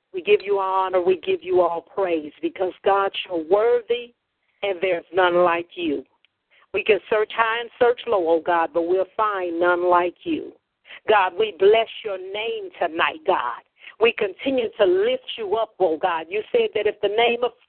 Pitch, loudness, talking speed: 215 Hz, -22 LUFS, 195 wpm